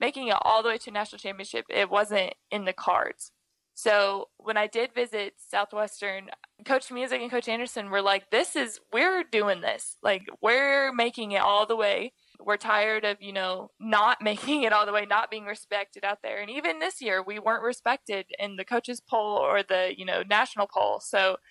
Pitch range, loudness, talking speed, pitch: 200-235 Hz, -27 LUFS, 200 wpm, 210 Hz